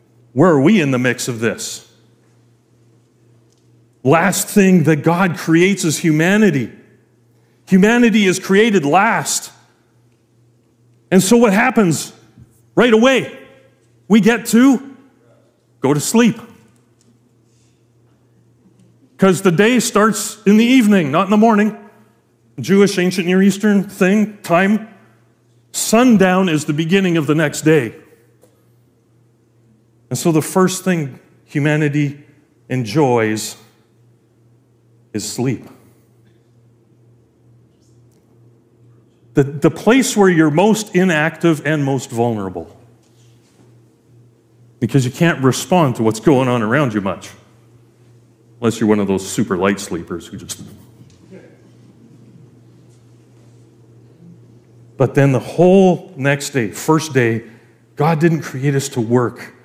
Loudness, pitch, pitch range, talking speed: -15 LUFS, 125 Hz, 115-175 Hz, 110 wpm